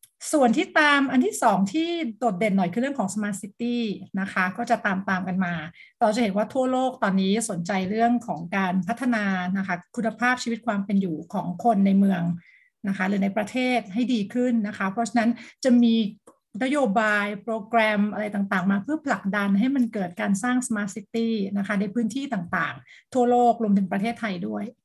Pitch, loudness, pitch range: 220 Hz, -24 LUFS, 195-240 Hz